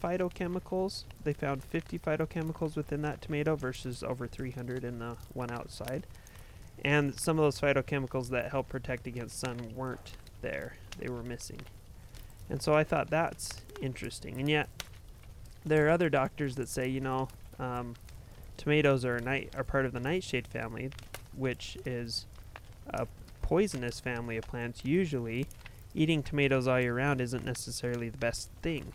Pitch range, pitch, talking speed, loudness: 120-145 Hz, 130 Hz, 155 wpm, -33 LUFS